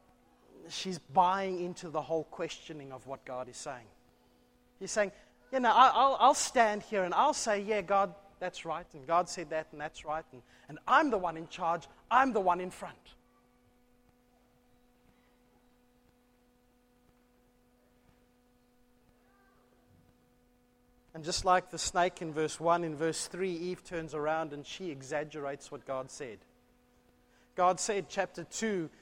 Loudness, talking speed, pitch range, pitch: -32 LUFS, 145 wpm, 125-190 Hz, 165 Hz